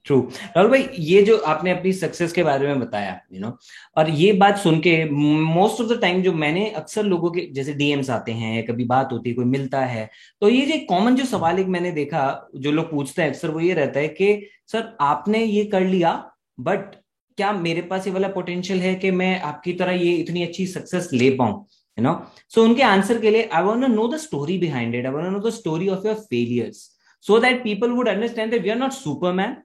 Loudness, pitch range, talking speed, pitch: -20 LUFS, 150-210 Hz, 220 wpm, 180 Hz